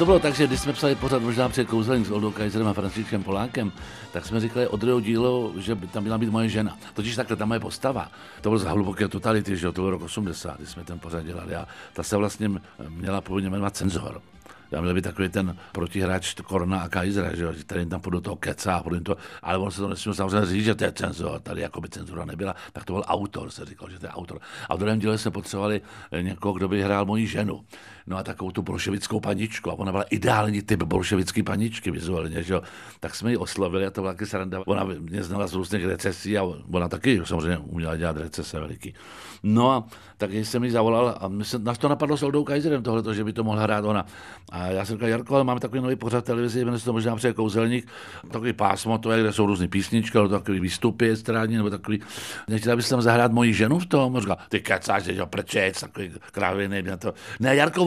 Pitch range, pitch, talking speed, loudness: 95-115 Hz, 105 Hz, 225 wpm, -25 LUFS